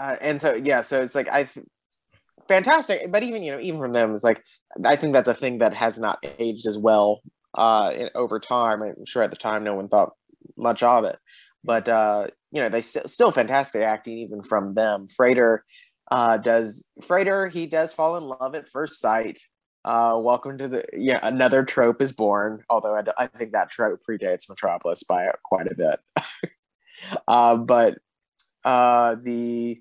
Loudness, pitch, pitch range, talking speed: -22 LUFS, 120 Hz, 110-135 Hz, 190 wpm